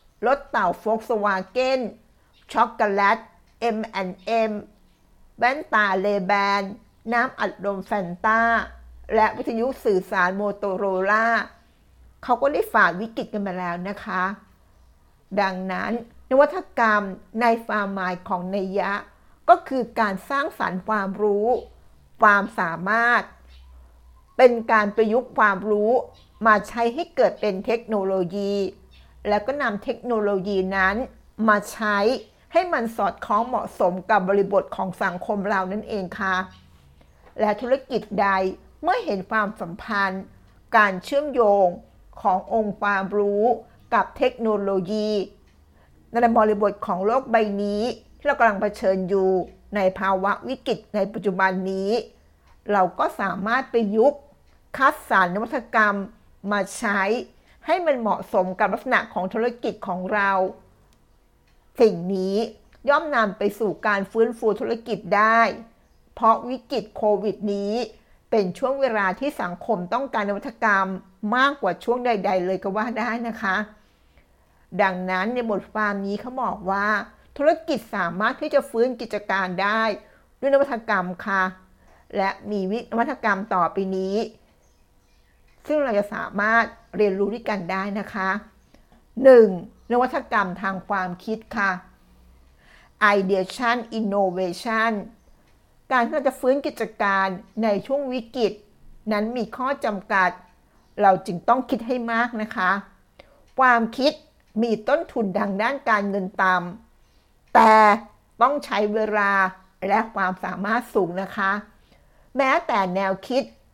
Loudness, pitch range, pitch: -22 LUFS, 190-230 Hz, 210 Hz